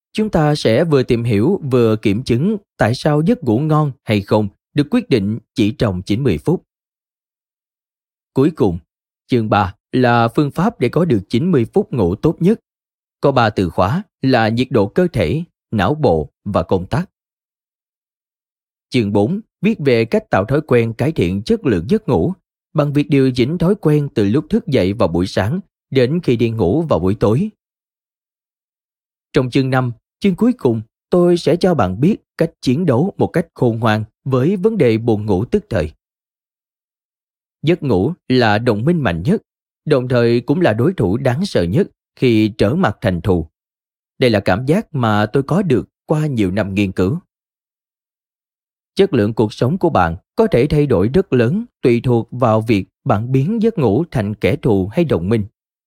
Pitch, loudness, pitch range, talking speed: 125 Hz, -16 LUFS, 105-160 Hz, 185 wpm